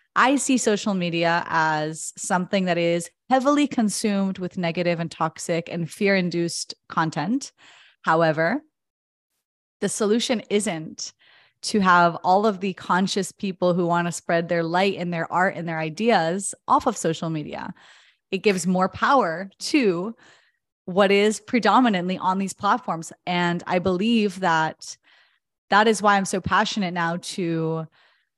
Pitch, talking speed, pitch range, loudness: 185 Hz, 145 wpm, 170-210 Hz, -22 LUFS